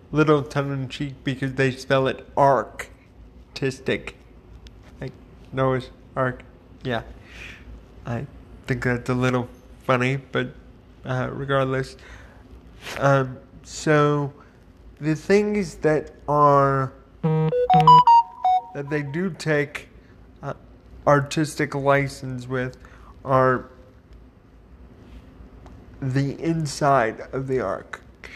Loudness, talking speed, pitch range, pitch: -22 LUFS, 90 wpm, 125-145 Hz, 135 Hz